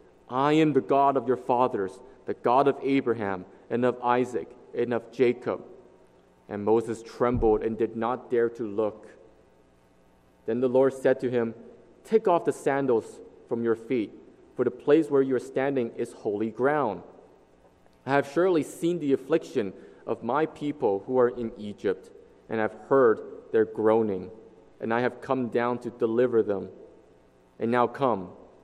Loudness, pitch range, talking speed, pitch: -27 LUFS, 115-140 Hz, 165 wpm, 125 Hz